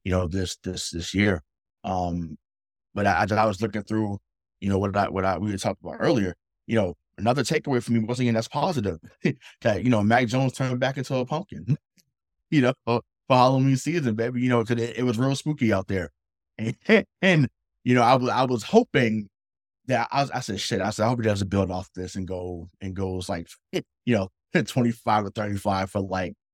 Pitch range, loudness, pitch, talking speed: 95-125 Hz, -25 LUFS, 110 Hz, 225 wpm